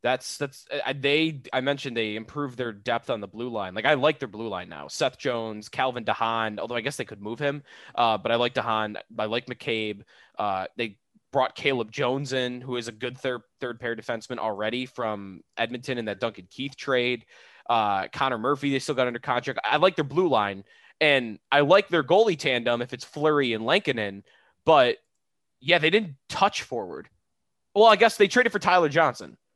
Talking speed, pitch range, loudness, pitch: 200 wpm, 110-140 Hz, -25 LUFS, 125 Hz